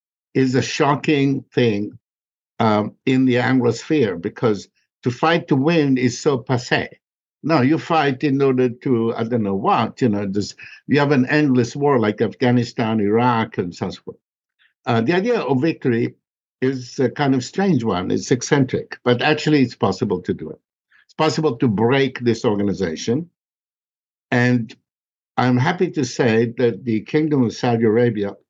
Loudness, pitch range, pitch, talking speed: -19 LUFS, 115-140 Hz, 125 Hz, 160 wpm